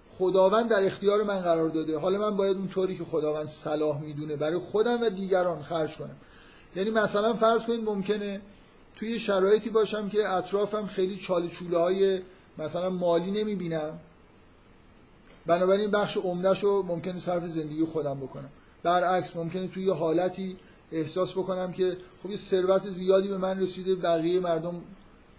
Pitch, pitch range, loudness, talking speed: 185 Hz, 165-195 Hz, -28 LUFS, 150 wpm